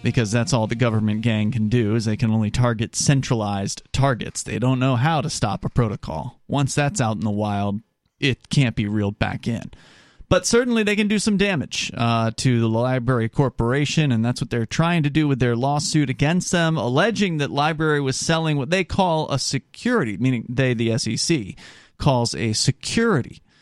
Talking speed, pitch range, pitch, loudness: 195 wpm, 115-150 Hz, 130 Hz, -21 LUFS